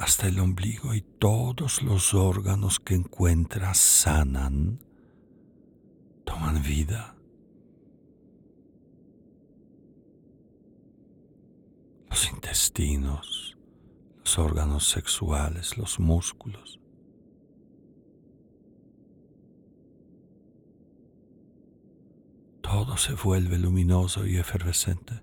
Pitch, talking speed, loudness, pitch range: 90 Hz, 60 wpm, -25 LUFS, 80-105 Hz